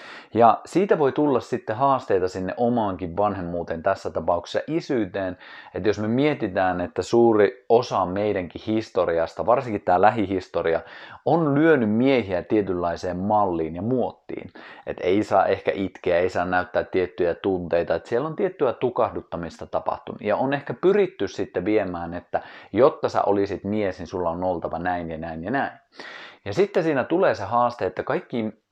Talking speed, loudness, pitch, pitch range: 155 wpm, -23 LUFS, 100 Hz, 90-120 Hz